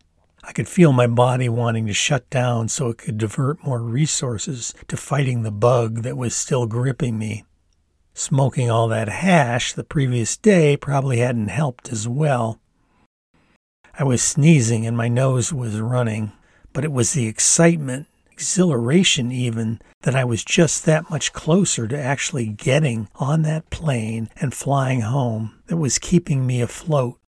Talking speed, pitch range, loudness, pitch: 160 wpm, 115-145 Hz, -20 LUFS, 125 Hz